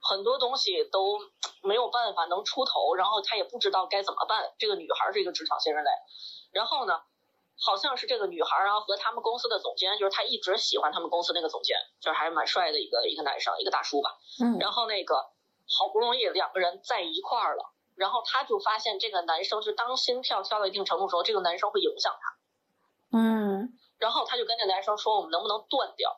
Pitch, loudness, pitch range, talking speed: 220 Hz, -28 LUFS, 195-270 Hz, 350 characters per minute